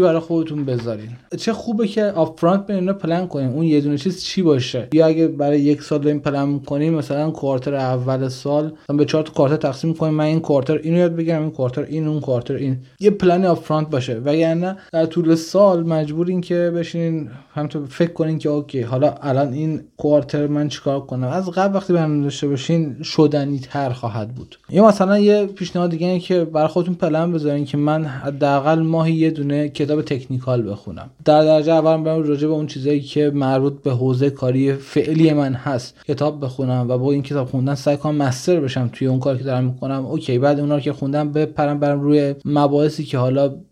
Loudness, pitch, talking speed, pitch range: -19 LUFS, 150 Hz, 200 wpm, 140-160 Hz